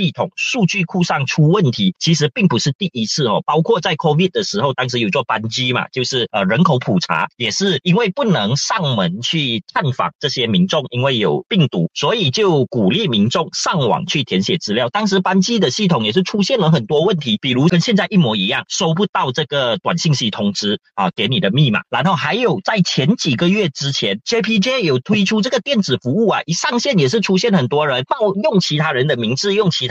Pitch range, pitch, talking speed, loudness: 140-195 Hz, 175 Hz, 330 characters per minute, -16 LUFS